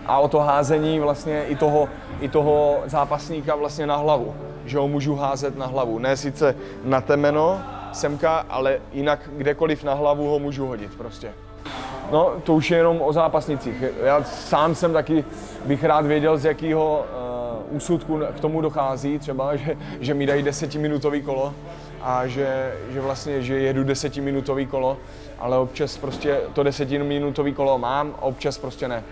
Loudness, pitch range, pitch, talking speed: -22 LUFS, 135-150 Hz, 145 Hz, 165 wpm